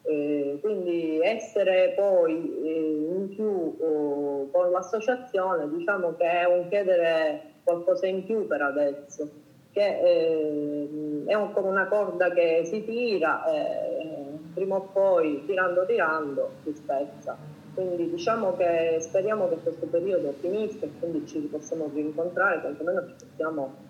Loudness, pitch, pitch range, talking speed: -26 LUFS, 175 Hz, 155-195 Hz, 130 wpm